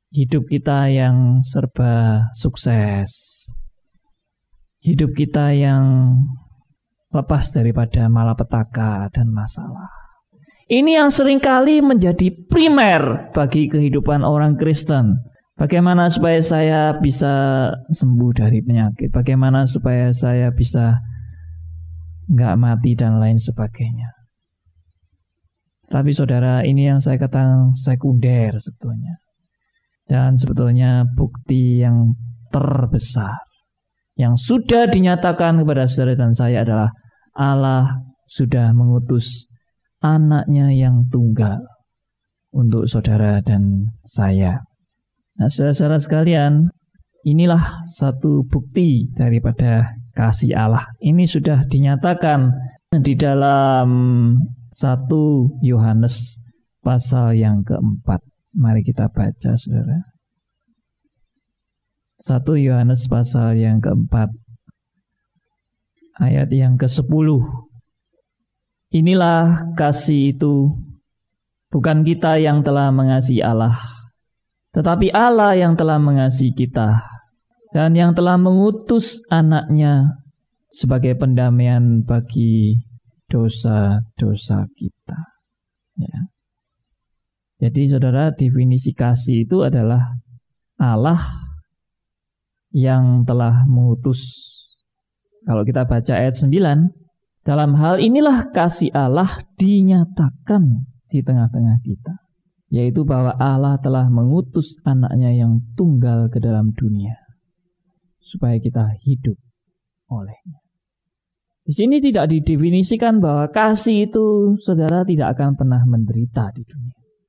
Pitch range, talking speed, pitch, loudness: 120-155 Hz, 90 wpm, 130 Hz, -16 LUFS